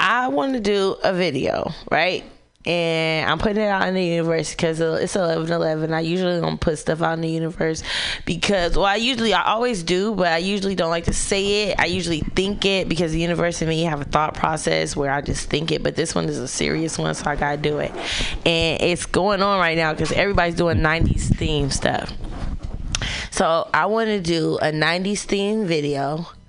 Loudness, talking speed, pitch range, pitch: -21 LUFS, 215 wpm, 160-195 Hz, 170 Hz